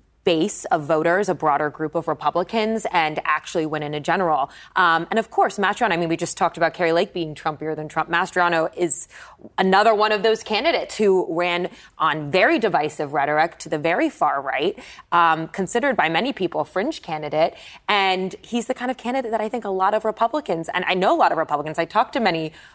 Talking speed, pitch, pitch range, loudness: 215 wpm, 175 Hz, 160-215 Hz, -21 LUFS